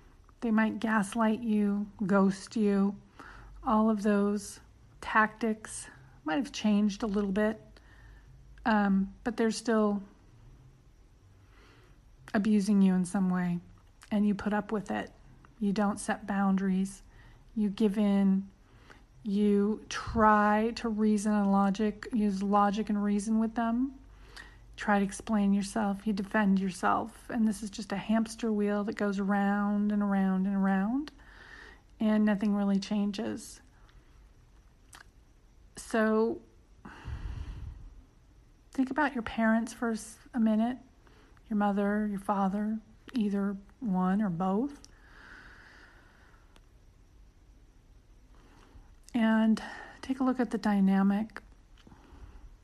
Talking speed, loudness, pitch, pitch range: 110 wpm, -30 LUFS, 205 Hz, 195-220 Hz